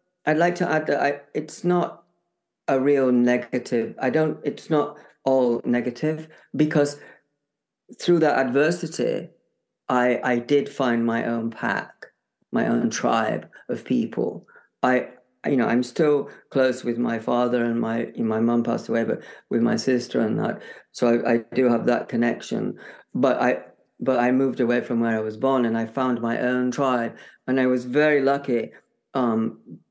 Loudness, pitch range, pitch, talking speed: -23 LUFS, 120-145 Hz, 130 Hz, 170 wpm